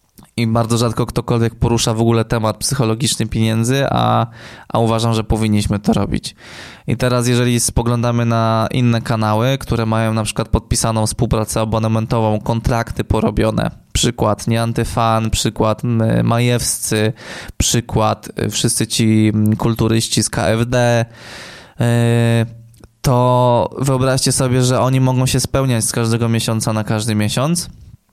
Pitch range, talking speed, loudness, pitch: 110-120 Hz, 120 wpm, -16 LUFS, 115 Hz